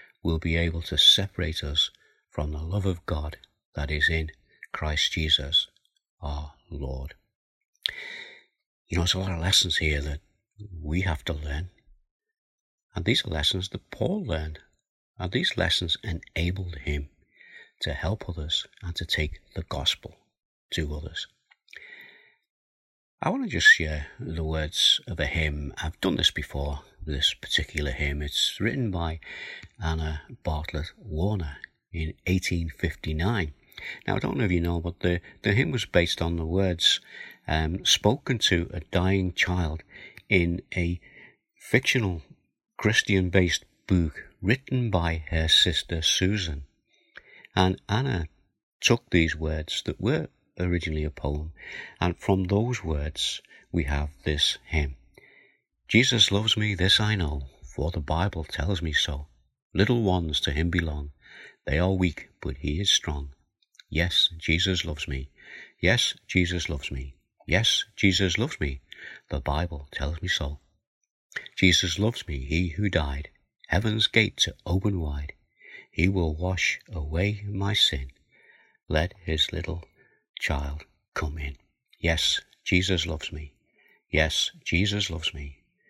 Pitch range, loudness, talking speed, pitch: 75-95 Hz, -26 LUFS, 140 wpm, 85 Hz